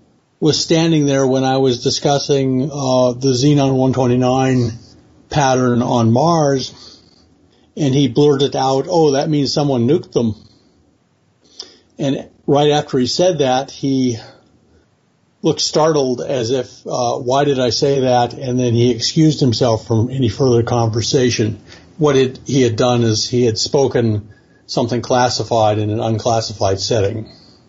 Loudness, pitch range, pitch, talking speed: -16 LUFS, 115-140 Hz, 125 Hz, 140 wpm